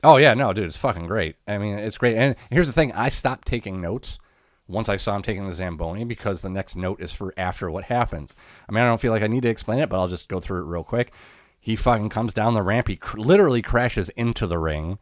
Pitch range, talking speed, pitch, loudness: 95-120 Hz, 270 wpm, 105 Hz, -23 LUFS